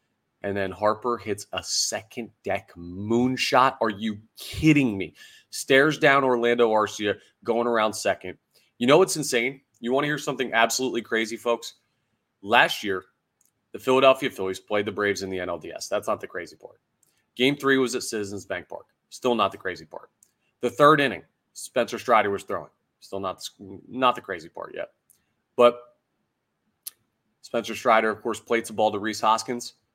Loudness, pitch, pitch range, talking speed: -24 LUFS, 115 Hz, 105-130 Hz, 170 wpm